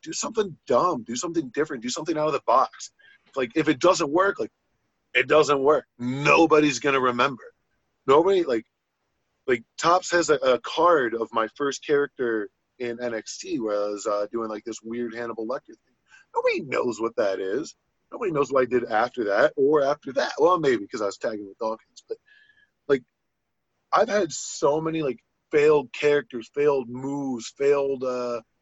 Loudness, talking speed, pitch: -24 LUFS, 180 wpm, 145 Hz